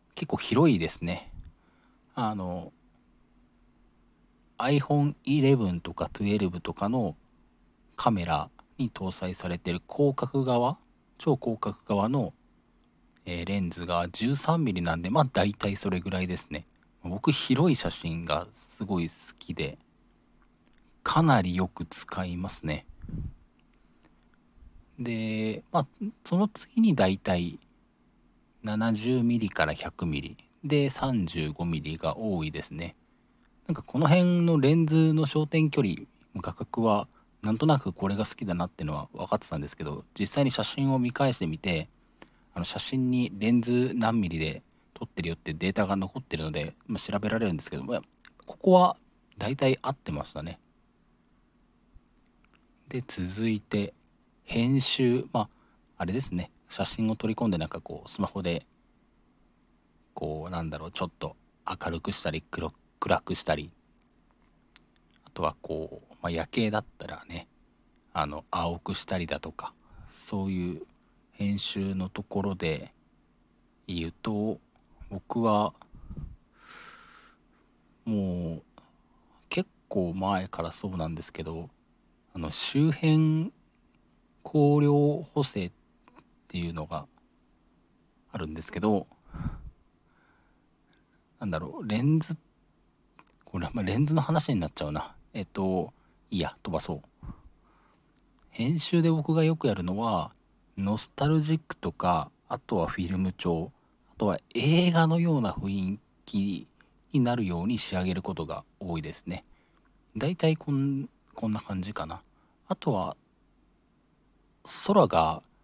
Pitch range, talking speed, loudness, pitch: 85-135 Hz, 235 characters per minute, -29 LUFS, 100 Hz